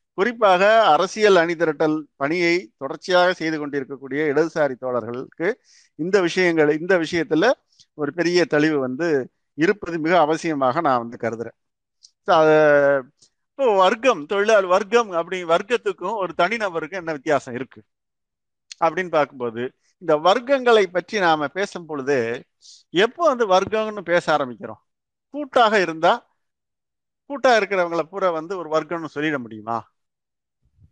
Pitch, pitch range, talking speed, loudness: 165 Hz, 145-190 Hz, 110 wpm, -20 LUFS